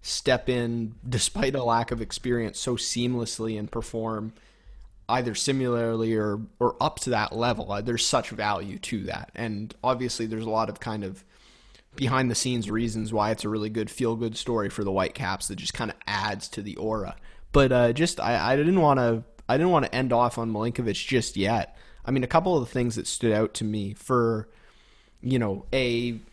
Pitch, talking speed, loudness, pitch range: 115 Hz, 205 wpm, -26 LUFS, 110-125 Hz